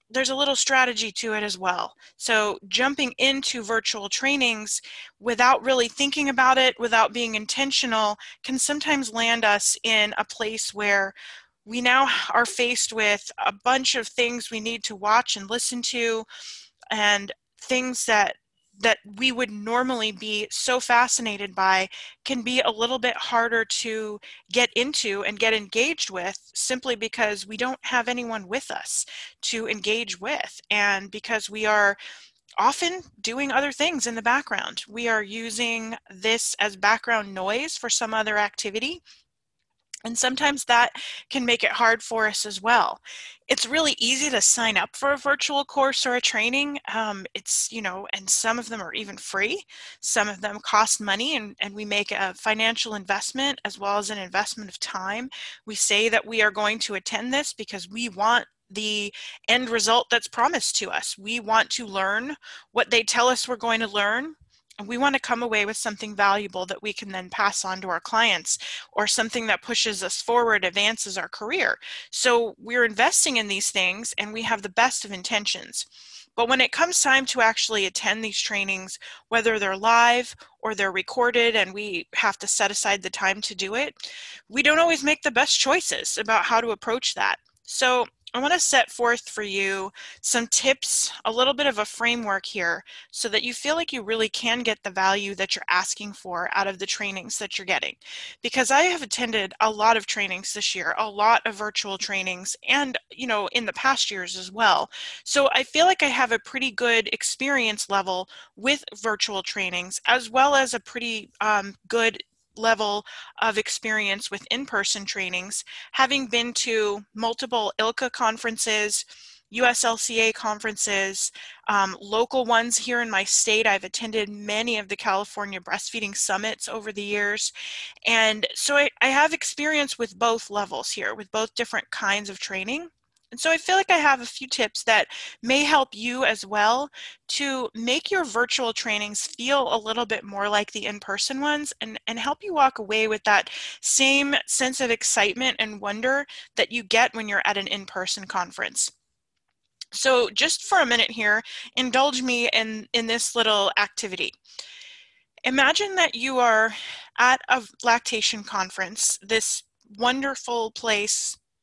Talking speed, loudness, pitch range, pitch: 175 wpm, -23 LUFS, 210-255 Hz, 225 Hz